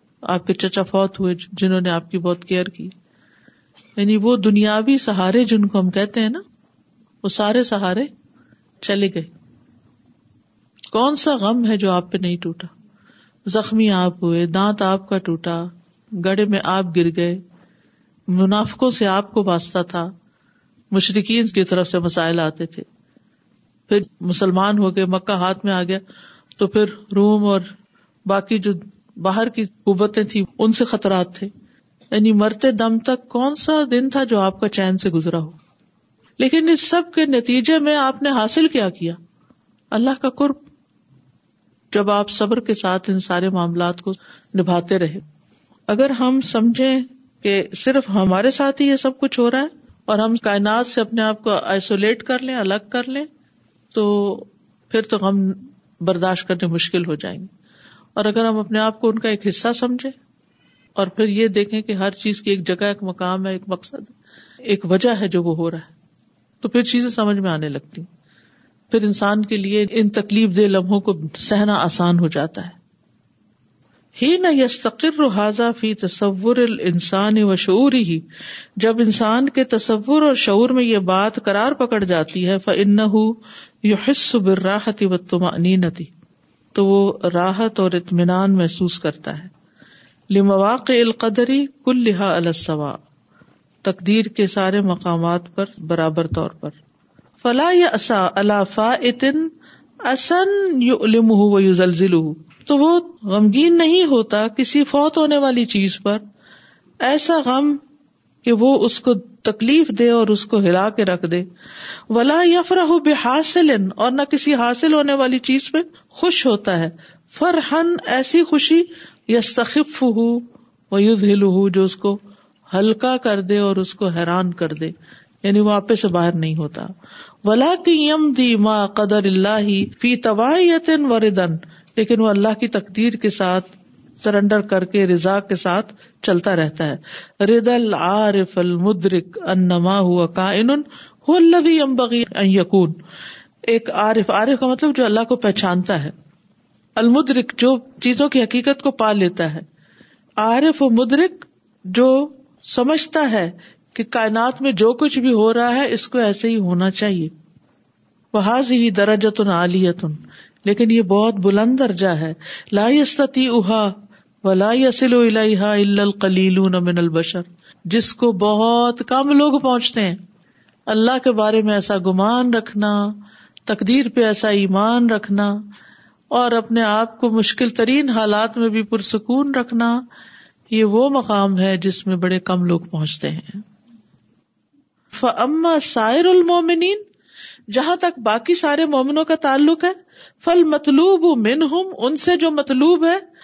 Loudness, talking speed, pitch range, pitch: -17 LUFS, 150 wpm, 190-250 Hz, 215 Hz